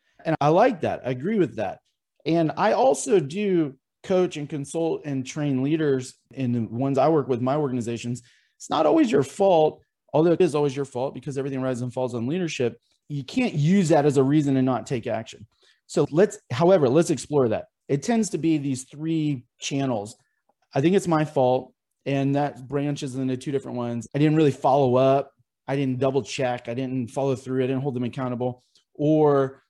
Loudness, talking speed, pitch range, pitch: -24 LUFS, 200 wpm, 130-155 Hz, 140 Hz